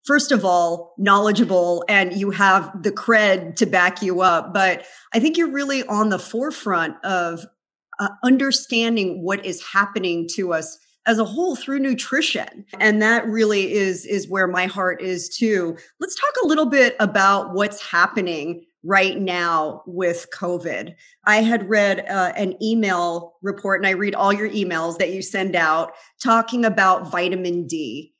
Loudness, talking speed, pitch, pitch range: -19 LUFS, 165 wpm, 195 Hz, 180-220 Hz